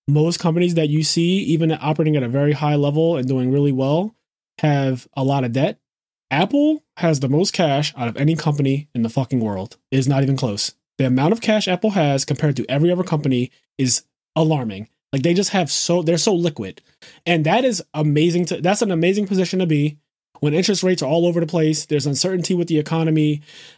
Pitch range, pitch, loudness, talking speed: 140-175 Hz, 155 Hz, -19 LUFS, 210 wpm